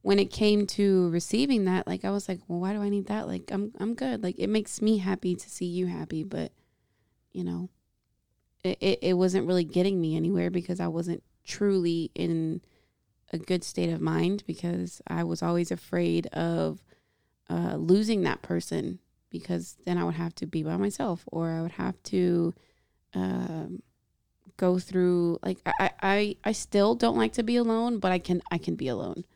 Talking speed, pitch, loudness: 190 wpm, 175 Hz, -28 LUFS